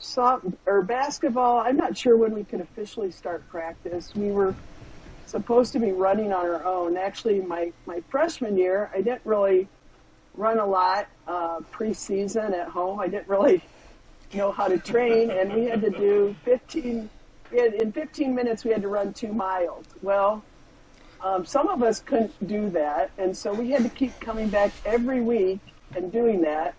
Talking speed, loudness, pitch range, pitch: 180 wpm, -25 LUFS, 190-235 Hz, 205 Hz